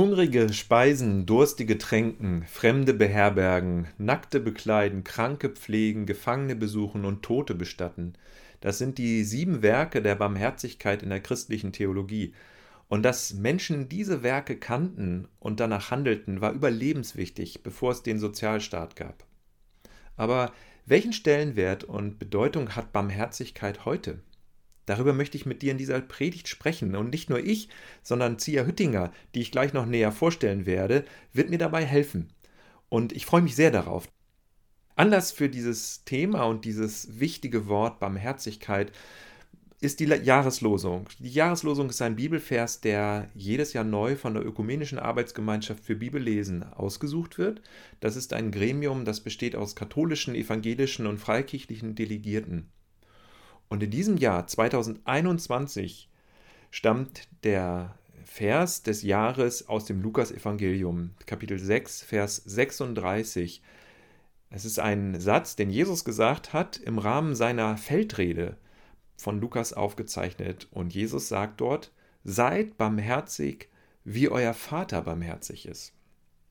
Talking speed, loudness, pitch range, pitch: 130 wpm, -28 LUFS, 100-130 Hz, 110 Hz